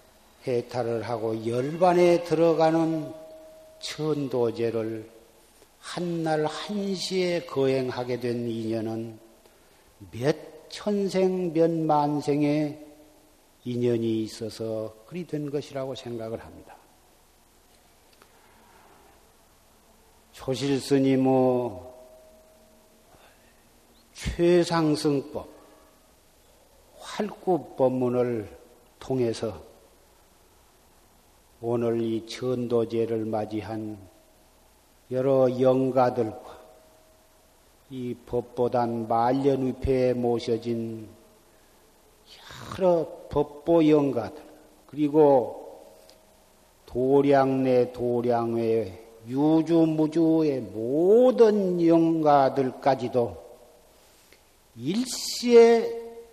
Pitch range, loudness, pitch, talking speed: 115-155 Hz, -25 LUFS, 130 Hz, 140 characters per minute